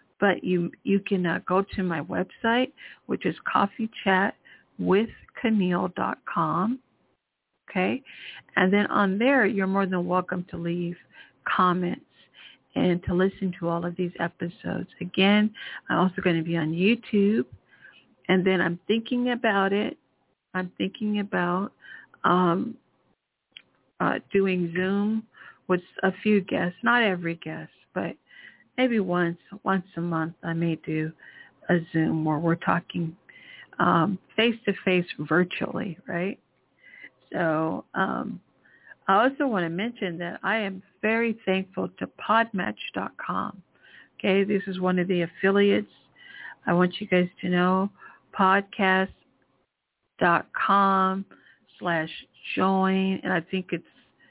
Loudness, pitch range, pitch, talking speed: -26 LUFS, 175-200 Hz, 190 Hz, 125 wpm